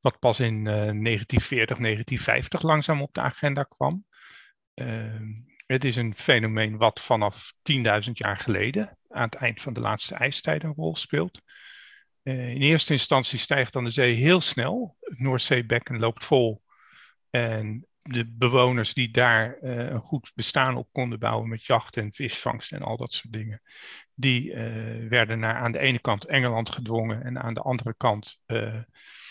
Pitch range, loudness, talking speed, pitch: 115-130 Hz, -25 LUFS, 170 wpm, 120 Hz